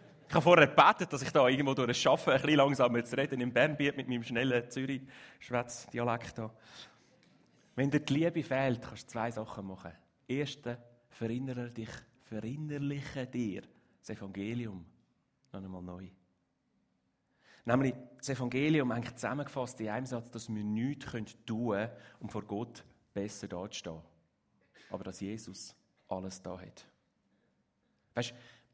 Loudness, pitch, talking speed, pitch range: -33 LUFS, 120 Hz, 140 wpm, 105-130 Hz